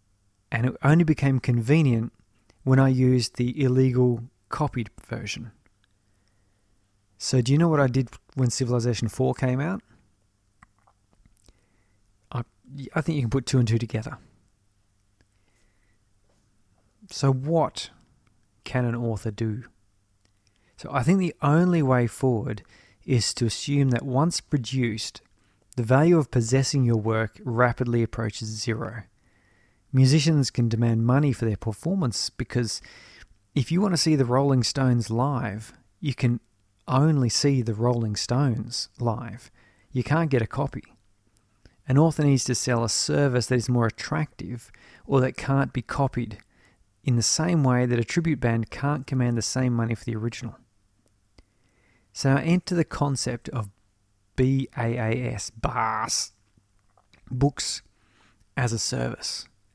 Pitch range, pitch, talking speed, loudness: 105-130 Hz, 120 Hz, 135 wpm, -25 LUFS